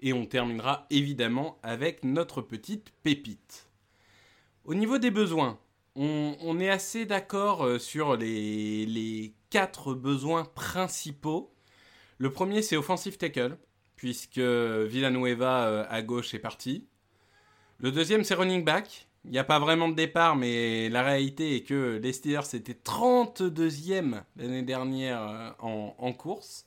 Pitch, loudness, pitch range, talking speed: 135 Hz, -29 LUFS, 115-165 Hz, 135 wpm